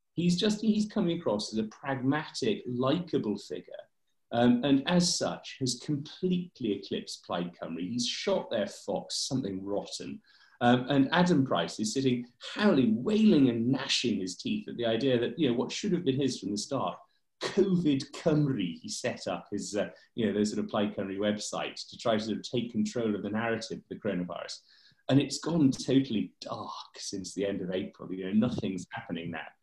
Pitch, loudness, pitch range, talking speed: 130 Hz, -30 LUFS, 110-160 Hz, 190 wpm